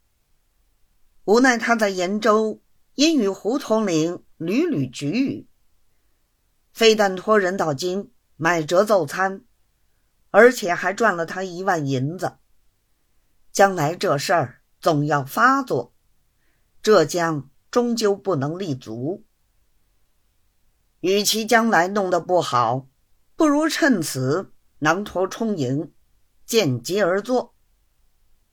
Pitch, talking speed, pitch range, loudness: 180 Hz, 150 characters per minute, 145-215 Hz, -21 LUFS